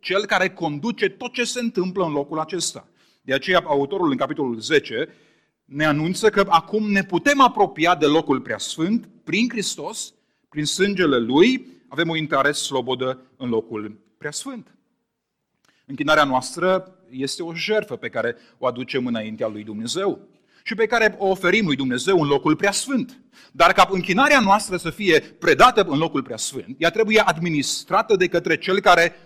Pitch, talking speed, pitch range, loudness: 175 Hz, 165 wpm, 145-205 Hz, -20 LUFS